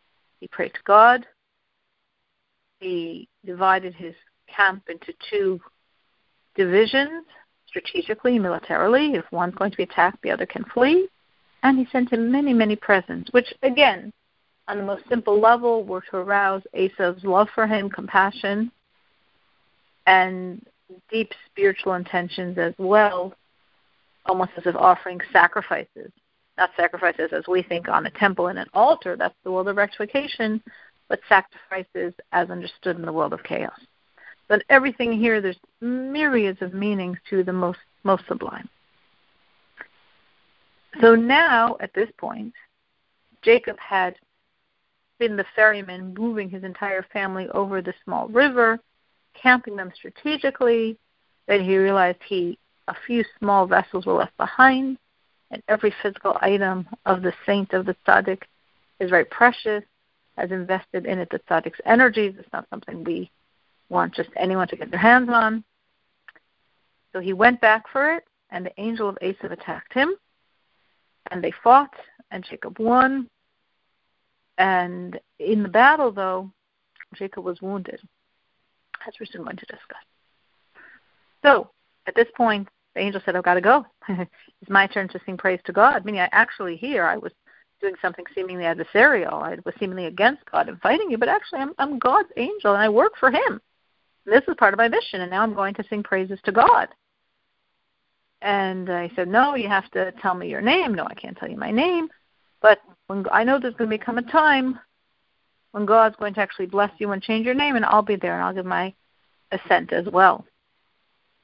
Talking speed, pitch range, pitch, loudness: 165 wpm, 185-235 Hz, 205 Hz, -21 LUFS